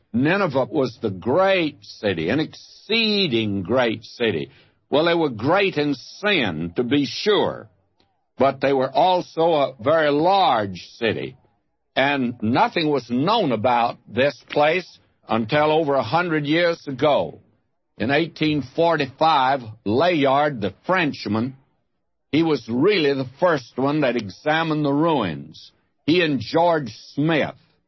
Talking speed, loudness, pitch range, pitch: 125 wpm, -21 LUFS, 125-160 Hz, 140 Hz